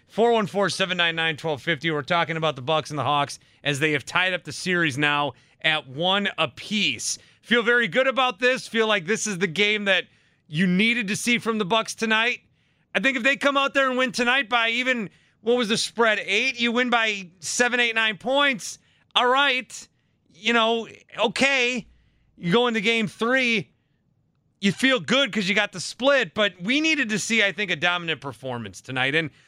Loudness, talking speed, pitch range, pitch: -22 LUFS, 205 wpm, 165-240 Hz, 210 Hz